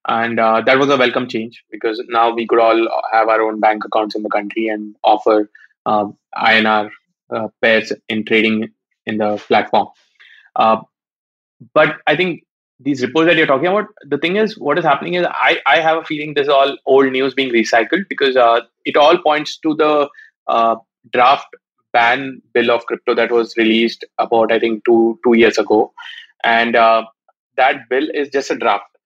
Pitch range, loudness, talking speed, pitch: 110-145 Hz, -15 LUFS, 190 wpm, 115 Hz